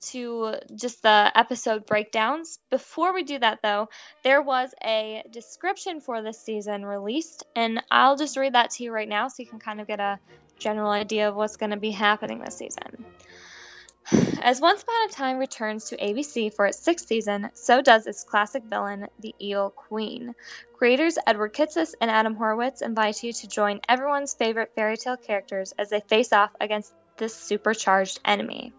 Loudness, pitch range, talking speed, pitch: -24 LUFS, 210-255 Hz, 180 wpm, 225 Hz